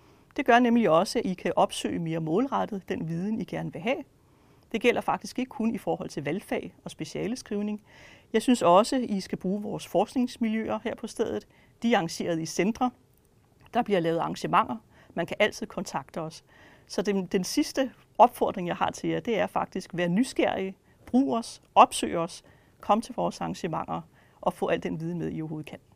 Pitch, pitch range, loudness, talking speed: 205 Hz, 170-235 Hz, -28 LUFS, 195 wpm